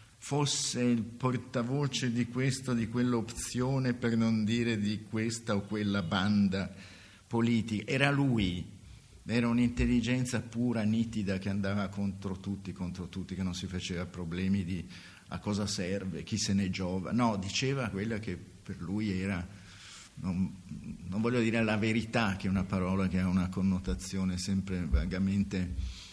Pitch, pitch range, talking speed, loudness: 100 Hz, 95-115 Hz, 145 wpm, -32 LUFS